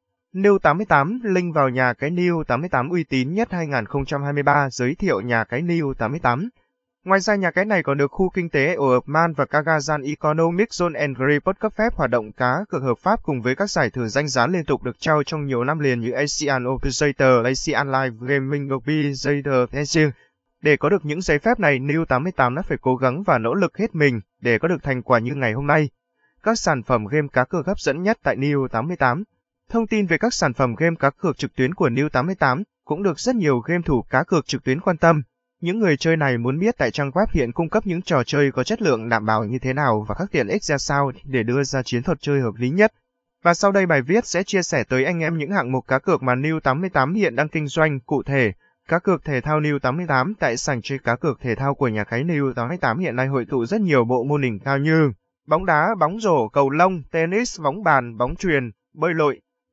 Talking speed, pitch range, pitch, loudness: 235 wpm, 130-175 Hz, 145 Hz, -21 LUFS